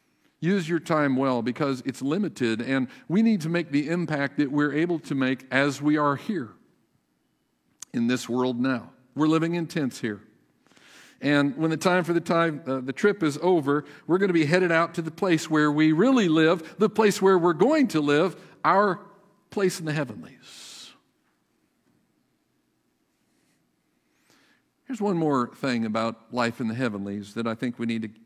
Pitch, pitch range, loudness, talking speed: 150 Hz, 130-175 Hz, -25 LUFS, 180 wpm